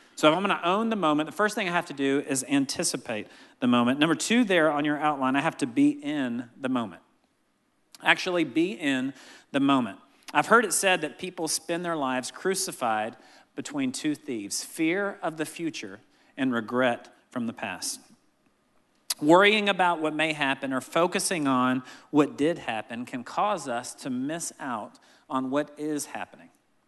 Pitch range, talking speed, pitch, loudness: 140-210 Hz, 180 wpm, 160 Hz, -26 LUFS